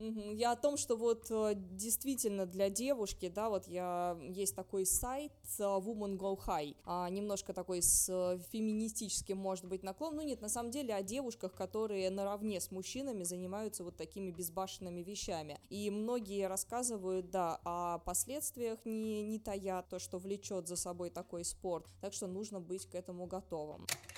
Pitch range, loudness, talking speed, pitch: 180-220 Hz, -39 LUFS, 155 wpm, 195 Hz